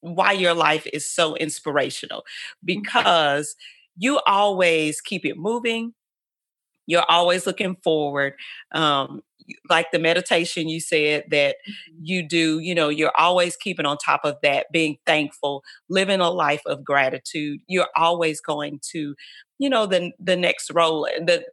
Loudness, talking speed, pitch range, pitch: -21 LUFS, 145 wpm, 150-185 Hz, 170 Hz